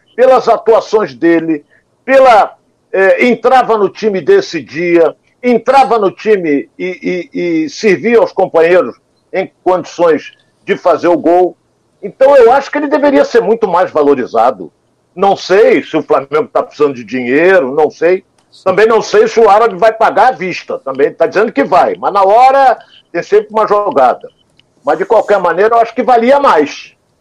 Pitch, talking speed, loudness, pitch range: 215 Hz, 170 wpm, -10 LUFS, 180-255 Hz